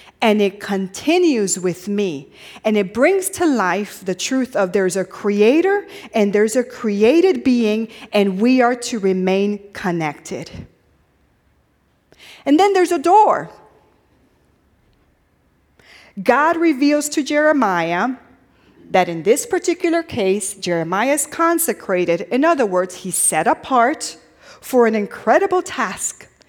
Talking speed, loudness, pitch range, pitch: 120 wpm, -17 LUFS, 195-300 Hz, 225 Hz